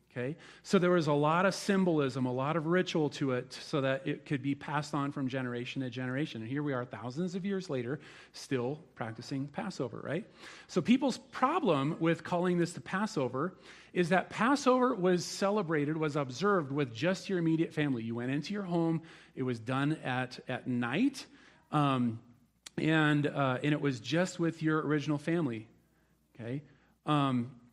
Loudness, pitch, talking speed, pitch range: -32 LUFS, 150 Hz, 175 wpm, 130-180 Hz